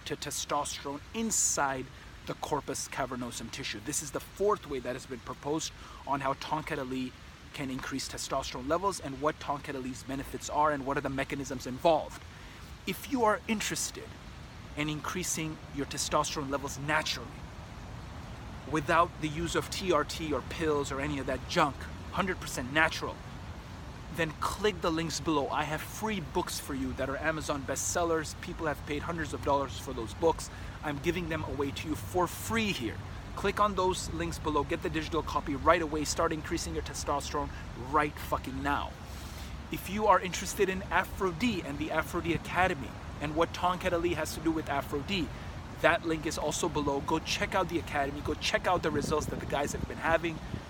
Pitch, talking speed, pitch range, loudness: 150 Hz, 175 wpm, 135-165 Hz, -32 LUFS